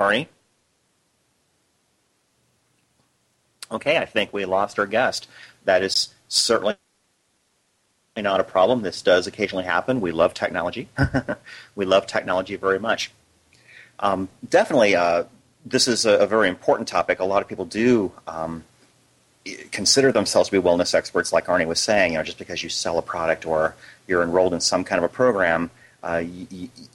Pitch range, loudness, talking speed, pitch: 85-115 Hz, -21 LUFS, 160 wpm, 95 Hz